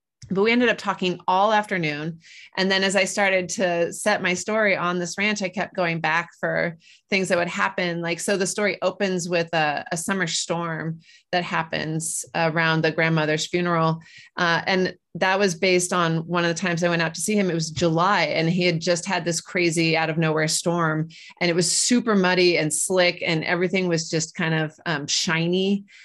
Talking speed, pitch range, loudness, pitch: 205 wpm, 165-190 Hz, -22 LUFS, 175 Hz